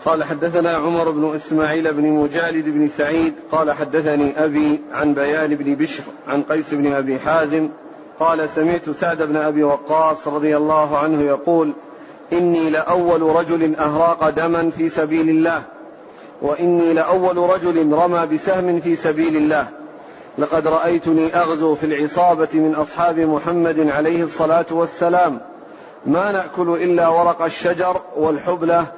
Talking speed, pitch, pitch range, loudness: 135 wpm, 160 Hz, 155-170 Hz, -18 LUFS